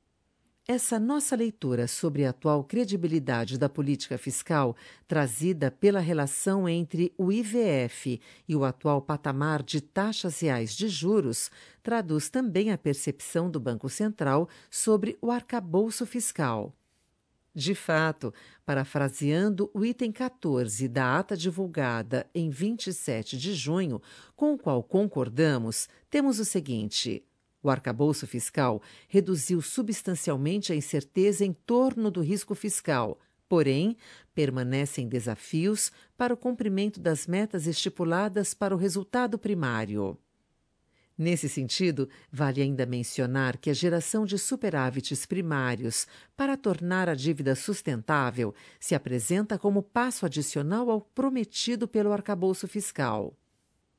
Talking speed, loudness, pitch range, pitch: 120 wpm, -28 LUFS, 140-205 Hz, 170 Hz